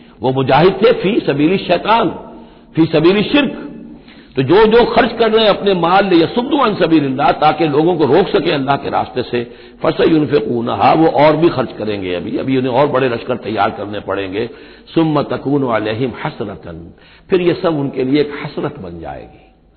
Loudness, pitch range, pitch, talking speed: -14 LUFS, 120-175 Hz, 150 Hz, 190 wpm